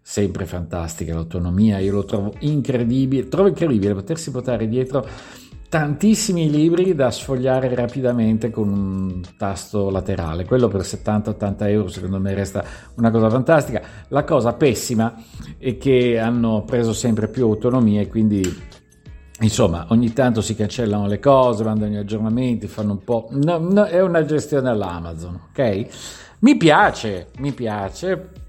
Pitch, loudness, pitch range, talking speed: 110 Hz, -19 LUFS, 100-130 Hz, 135 wpm